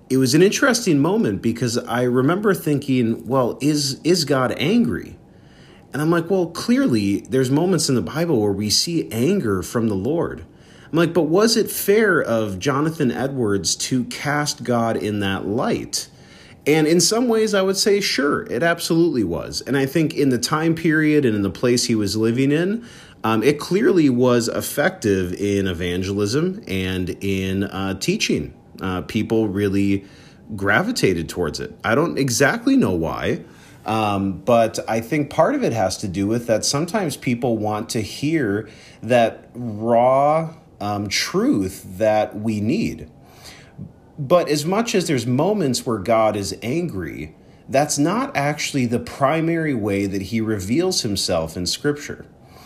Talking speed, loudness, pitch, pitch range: 160 wpm, -20 LUFS, 125 Hz, 105-160 Hz